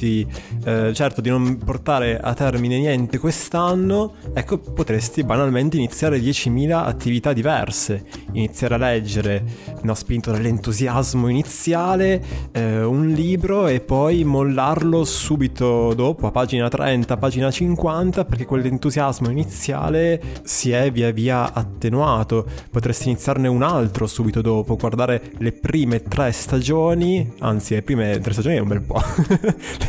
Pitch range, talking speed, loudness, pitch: 115-150 Hz, 130 wpm, -20 LUFS, 125 Hz